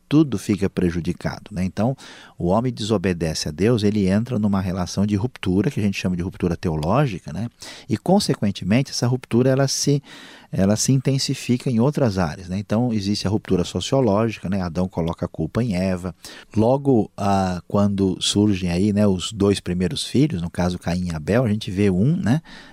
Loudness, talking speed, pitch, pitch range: -21 LUFS, 185 wpm, 100 Hz, 90-120 Hz